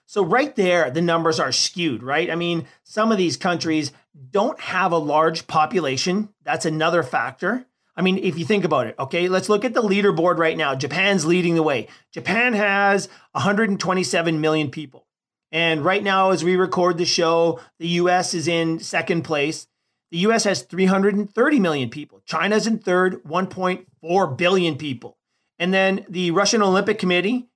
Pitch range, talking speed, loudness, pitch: 165-195 Hz, 170 wpm, -20 LUFS, 180 Hz